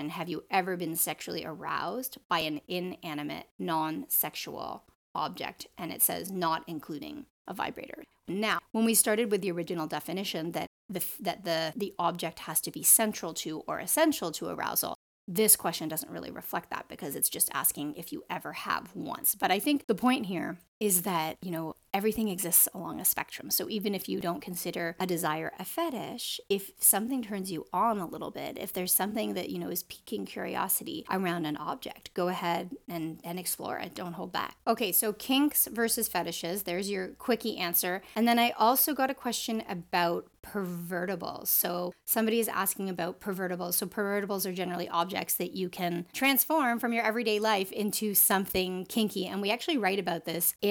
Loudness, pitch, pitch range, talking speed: -30 LUFS, 190 Hz, 170-220 Hz, 185 wpm